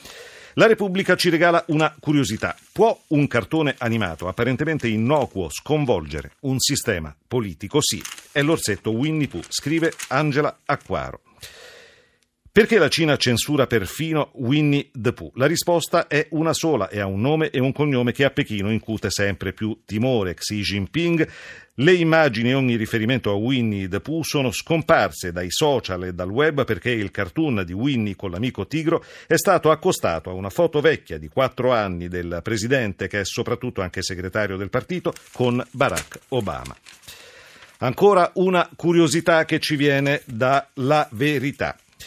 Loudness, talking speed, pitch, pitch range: -21 LUFS, 155 wpm, 130 Hz, 105-155 Hz